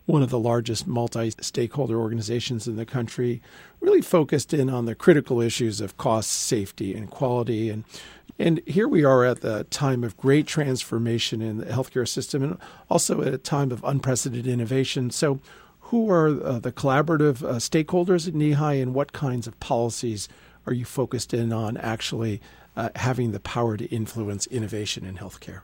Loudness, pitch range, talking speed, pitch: -24 LUFS, 115-140 Hz, 170 wpm, 125 Hz